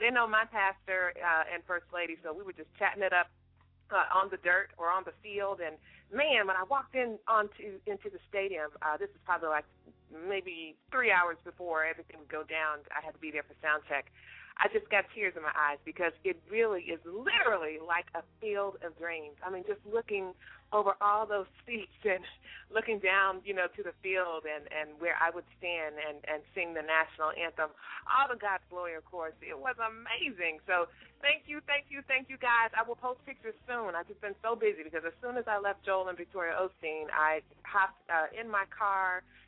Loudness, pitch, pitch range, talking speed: -33 LUFS, 185 Hz, 160-210 Hz, 215 wpm